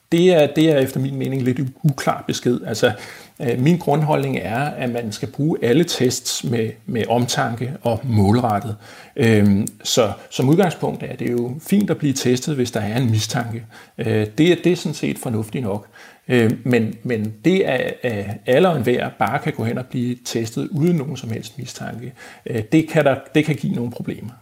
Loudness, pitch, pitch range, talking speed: -20 LUFS, 125 Hz, 115-145 Hz, 205 wpm